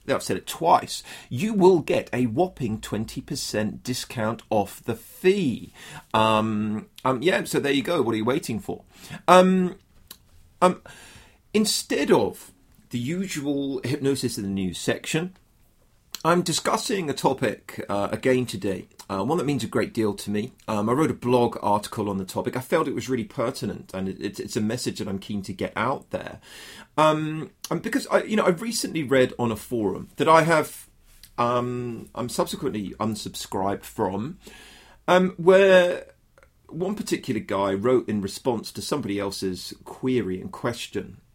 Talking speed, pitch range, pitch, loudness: 165 wpm, 105-160 Hz, 120 Hz, -24 LUFS